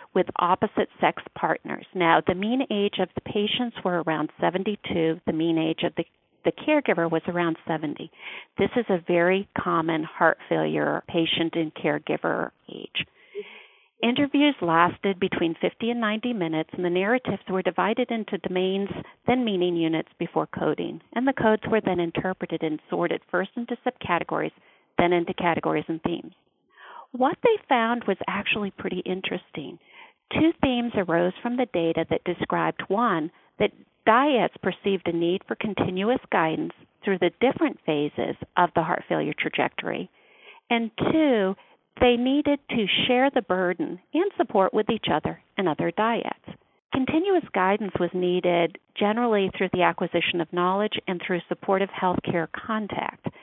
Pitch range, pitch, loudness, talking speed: 170-235 Hz, 190 Hz, -25 LUFS, 150 wpm